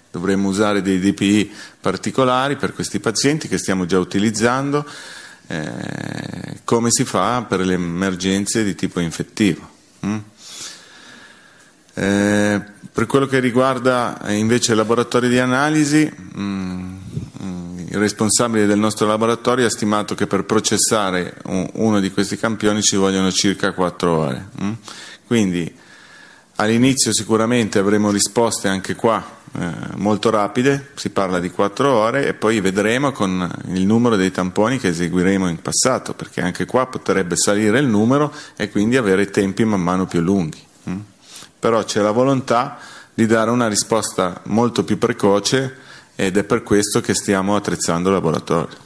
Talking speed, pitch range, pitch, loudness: 140 wpm, 95-115 Hz, 105 Hz, -18 LUFS